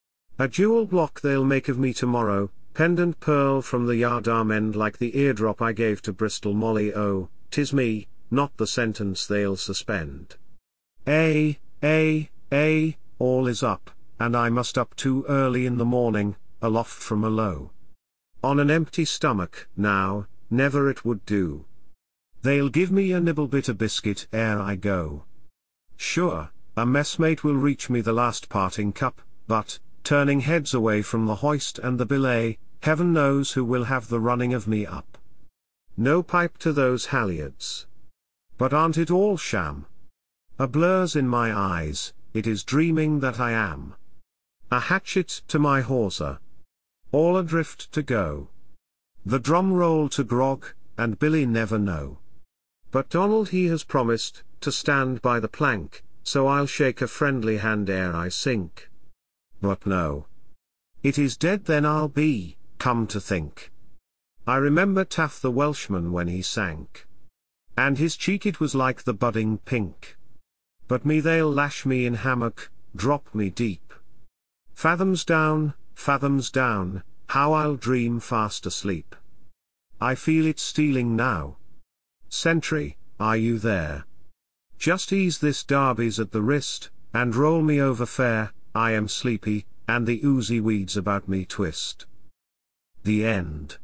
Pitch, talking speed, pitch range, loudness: 120 Hz, 150 wpm, 100-145 Hz, -24 LUFS